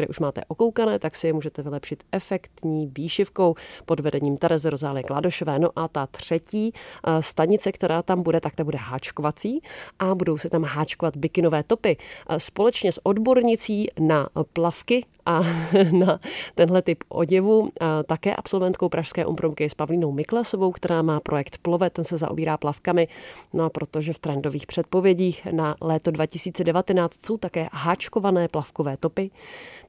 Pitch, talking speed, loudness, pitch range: 165 Hz, 150 wpm, -24 LUFS, 155-185 Hz